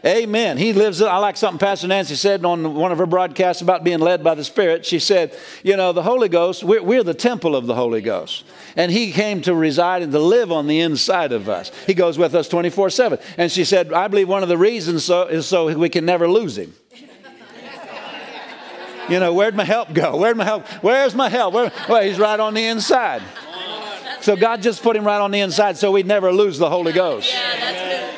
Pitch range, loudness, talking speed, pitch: 175-215 Hz, -17 LUFS, 230 wpm, 190 Hz